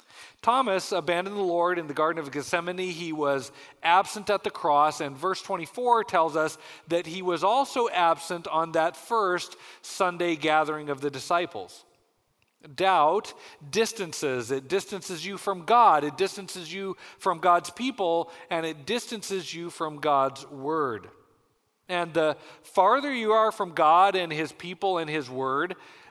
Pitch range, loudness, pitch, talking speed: 155-195 Hz, -26 LUFS, 175 Hz, 150 wpm